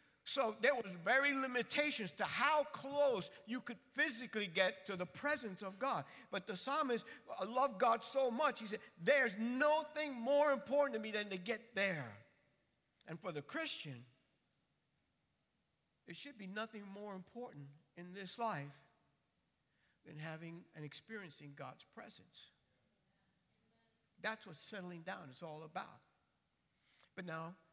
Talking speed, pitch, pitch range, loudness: 140 wpm, 210 Hz, 175-260 Hz, -39 LUFS